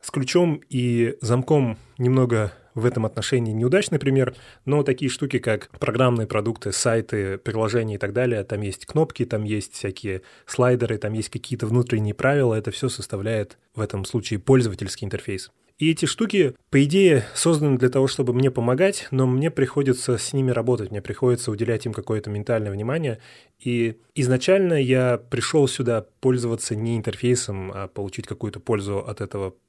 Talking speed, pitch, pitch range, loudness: 160 wpm, 120 Hz, 110-130 Hz, -23 LUFS